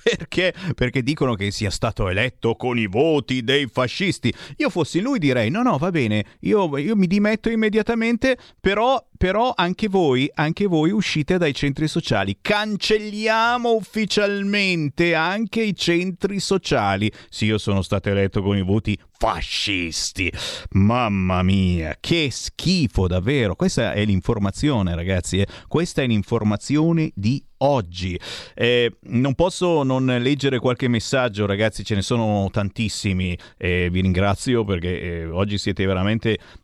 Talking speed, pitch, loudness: 140 wpm, 125 Hz, -21 LUFS